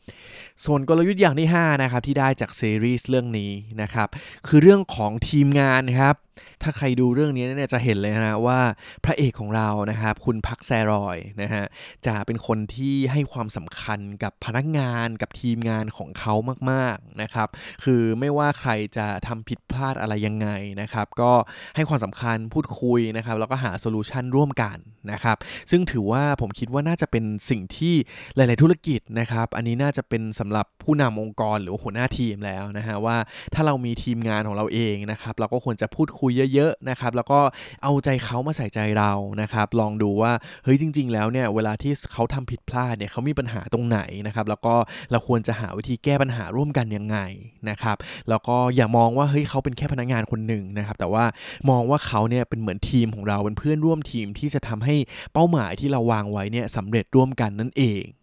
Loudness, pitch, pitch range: -23 LUFS, 115 Hz, 110-135 Hz